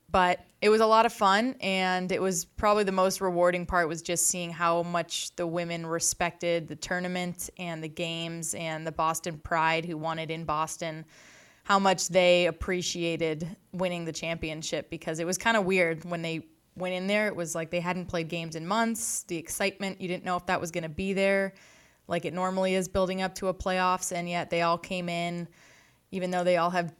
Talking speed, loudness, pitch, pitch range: 210 wpm, -28 LUFS, 175 Hz, 165-185 Hz